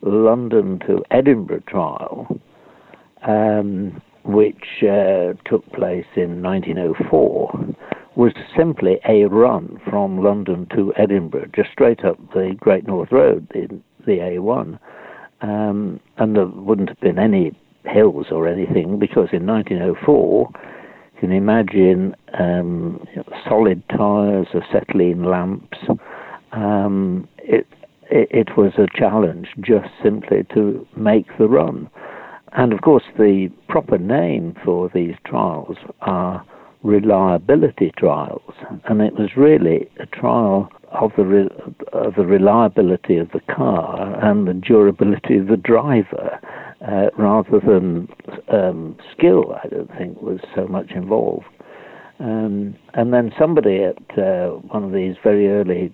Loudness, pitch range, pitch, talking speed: -17 LUFS, 95-105 Hz, 100 Hz, 130 wpm